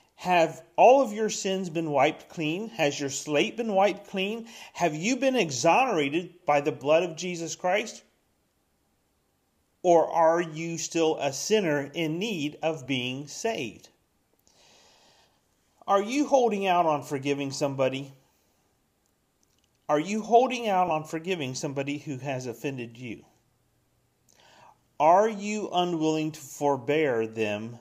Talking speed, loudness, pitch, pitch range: 125 wpm, -26 LUFS, 160 Hz, 140-190 Hz